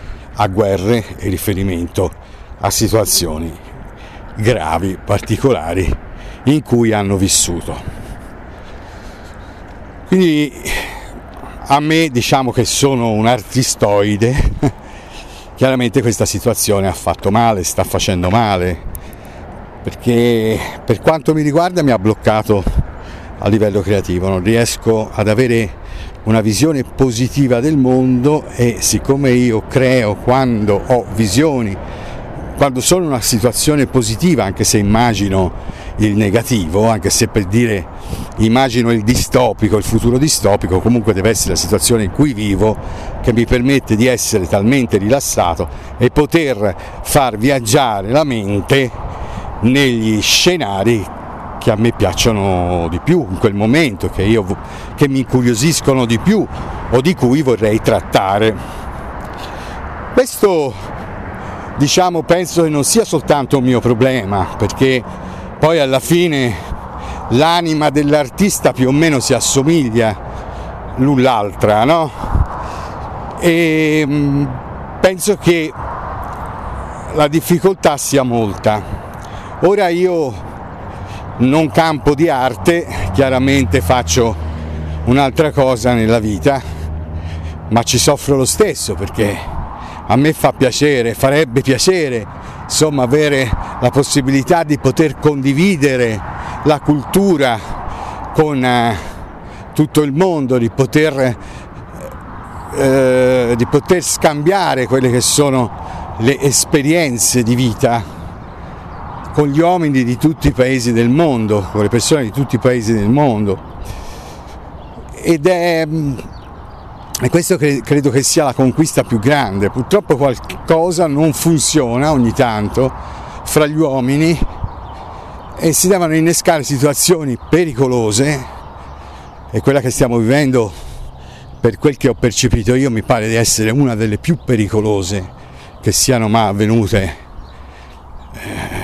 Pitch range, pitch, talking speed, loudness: 100-140 Hz, 120 Hz, 115 wpm, -14 LUFS